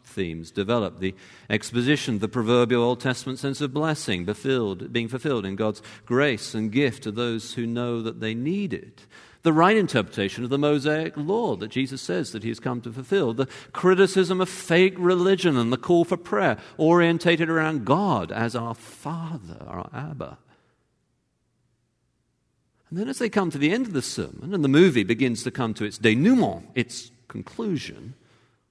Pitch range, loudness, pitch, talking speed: 115-165 Hz, -24 LUFS, 130 Hz, 175 wpm